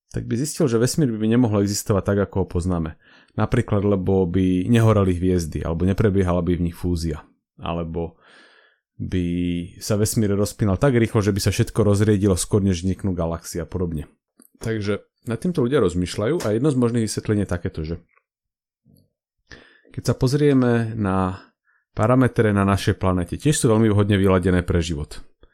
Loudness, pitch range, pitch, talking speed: -21 LUFS, 90-115 Hz, 100 Hz, 160 wpm